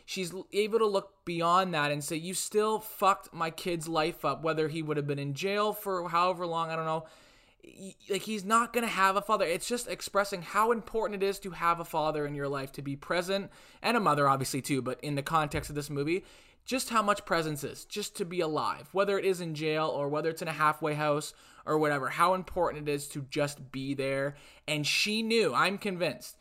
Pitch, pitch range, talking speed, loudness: 165 Hz, 150-195 Hz, 230 wpm, -30 LUFS